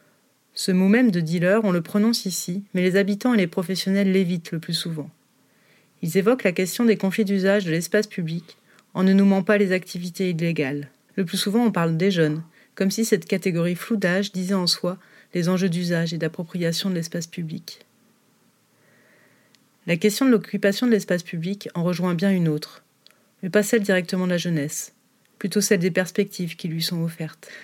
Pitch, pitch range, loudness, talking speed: 185 Hz, 170-200 Hz, -22 LUFS, 190 wpm